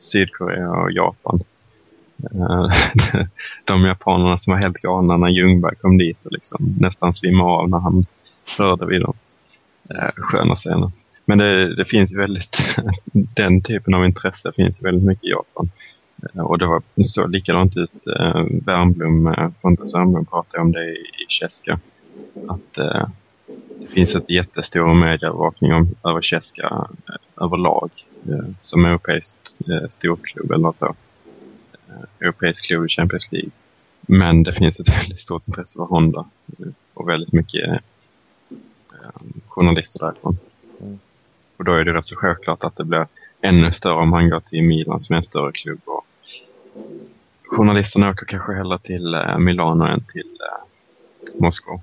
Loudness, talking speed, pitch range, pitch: -18 LUFS, 145 wpm, 85-95 Hz, 90 Hz